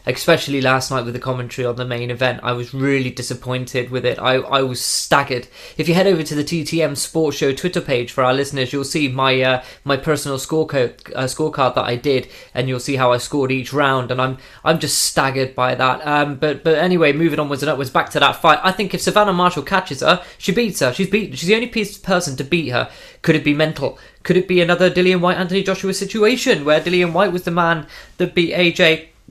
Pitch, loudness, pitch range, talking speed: 150 Hz, -18 LUFS, 130-175 Hz, 235 wpm